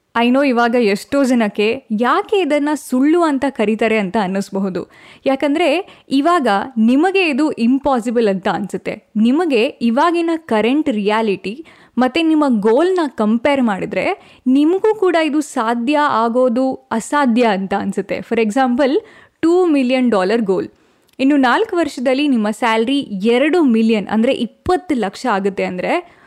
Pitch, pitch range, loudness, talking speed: 255 Hz, 225-295 Hz, -16 LUFS, 125 wpm